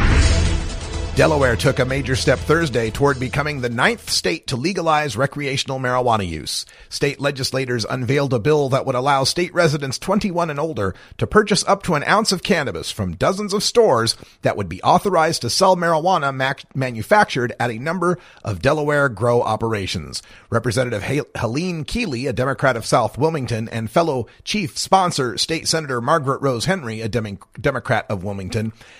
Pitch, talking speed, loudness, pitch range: 135 Hz, 160 wpm, -19 LUFS, 115-160 Hz